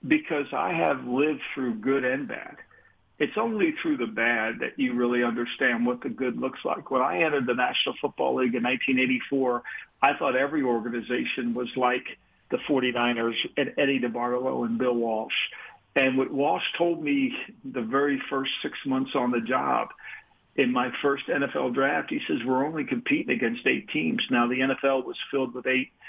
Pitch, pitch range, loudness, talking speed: 130 Hz, 120-140 Hz, -26 LUFS, 180 wpm